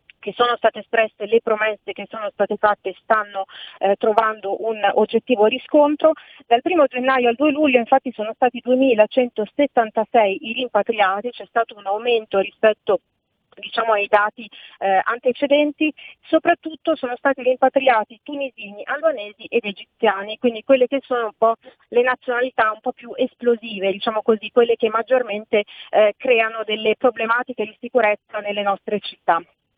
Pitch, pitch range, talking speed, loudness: 230 Hz, 210-255 Hz, 145 wpm, -20 LUFS